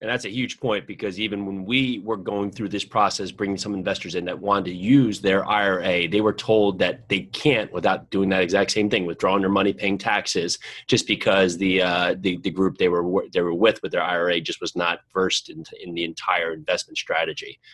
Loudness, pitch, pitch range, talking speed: -22 LUFS, 100 Hz, 95-105 Hz, 225 wpm